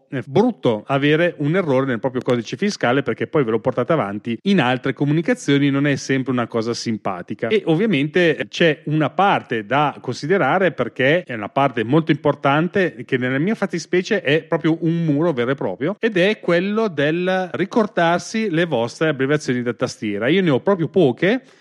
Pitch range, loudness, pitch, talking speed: 130-180 Hz, -19 LUFS, 155 Hz, 175 wpm